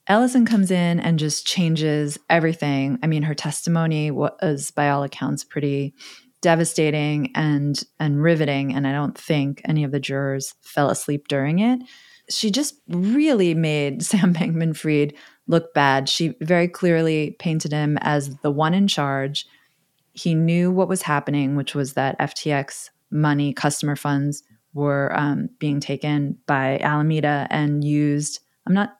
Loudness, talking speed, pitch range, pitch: -21 LUFS, 150 wpm, 145-170 Hz, 150 Hz